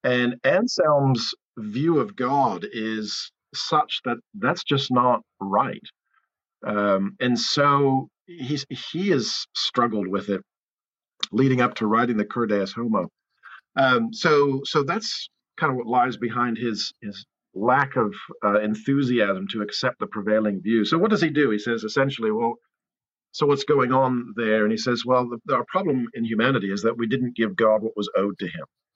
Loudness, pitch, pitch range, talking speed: -23 LUFS, 120 Hz, 110-140 Hz, 170 wpm